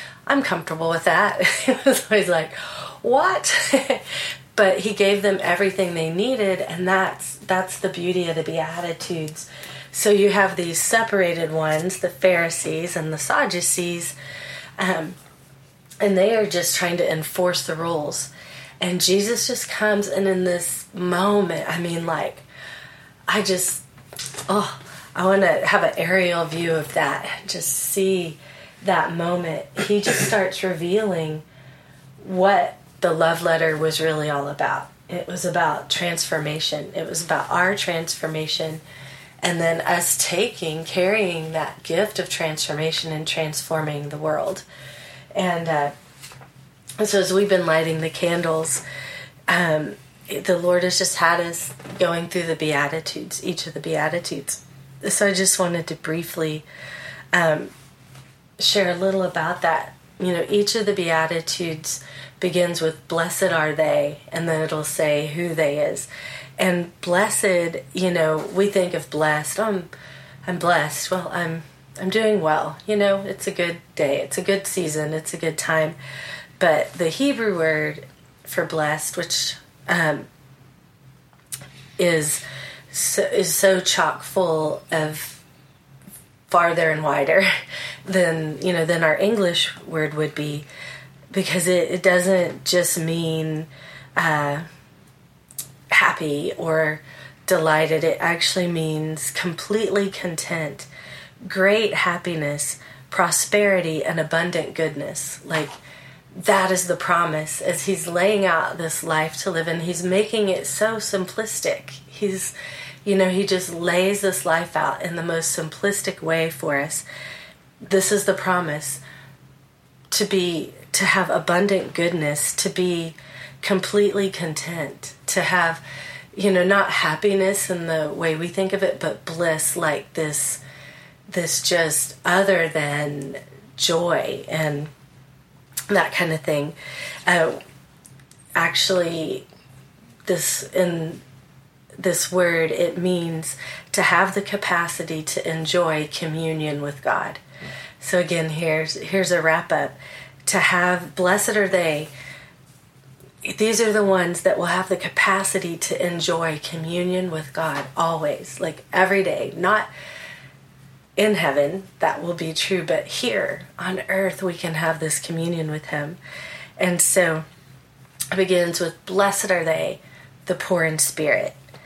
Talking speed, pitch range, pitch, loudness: 135 wpm, 150-185 Hz, 165 Hz, -21 LUFS